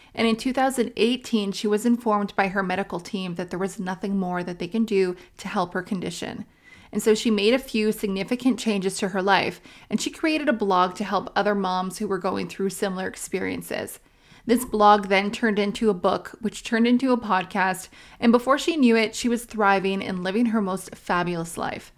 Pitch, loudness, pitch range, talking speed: 205 Hz, -24 LUFS, 190-225 Hz, 205 wpm